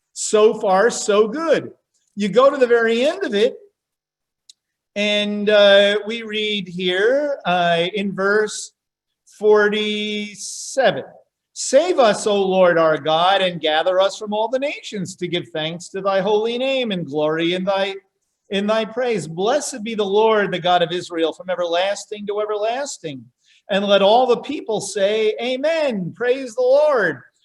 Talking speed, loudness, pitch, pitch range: 155 wpm, -18 LUFS, 210 Hz, 185-225 Hz